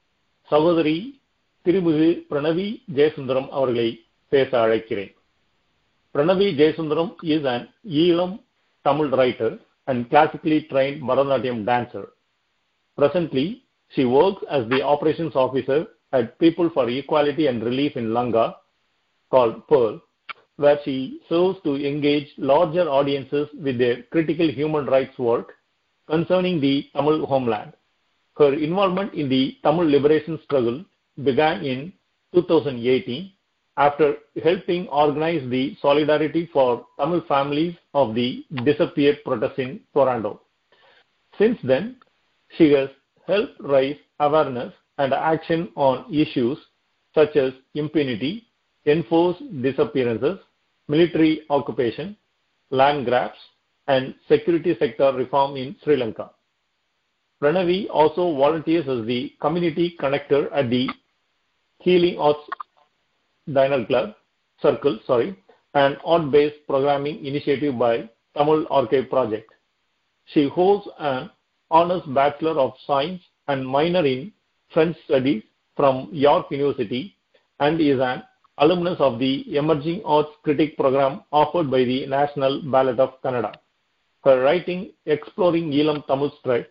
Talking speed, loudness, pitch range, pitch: 110 wpm, -21 LUFS, 135-165 Hz, 145 Hz